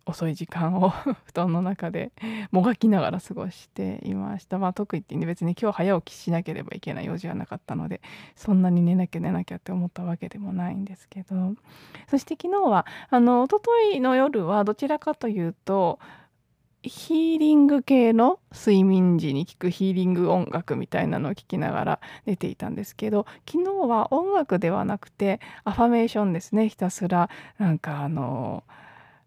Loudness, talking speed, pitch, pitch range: -24 LUFS, 370 characters per minute, 190 Hz, 175-230 Hz